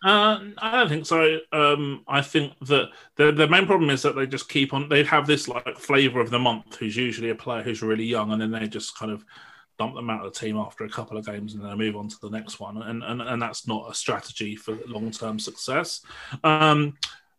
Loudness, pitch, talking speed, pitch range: -24 LUFS, 120 Hz, 250 wpm, 110-145 Hz